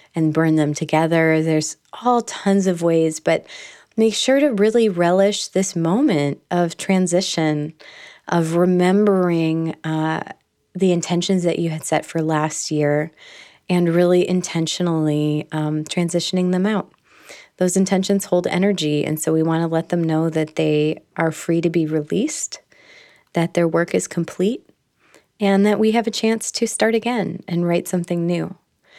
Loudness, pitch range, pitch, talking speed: -19 LUFS, 160-195 Hz, 175 Hz, 155 wpm